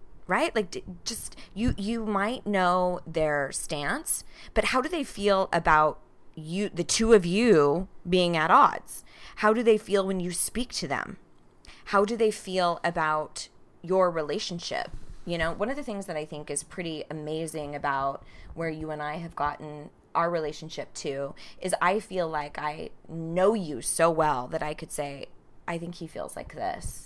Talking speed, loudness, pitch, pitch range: 175 wpm, -27 LUFS, 170 Hz, 155-200 Hz